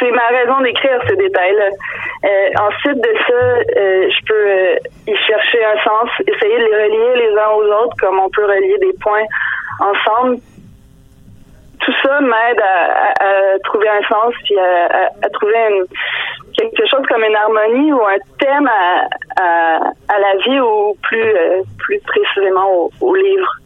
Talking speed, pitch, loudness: 175 wpm, 245 Hz, -13 LUFS